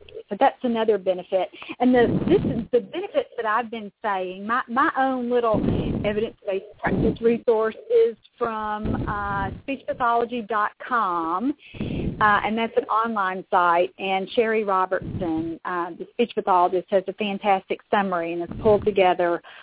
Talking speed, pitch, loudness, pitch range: 140 wpm, 210 Hz, -23 LUFS, 190-240 Hz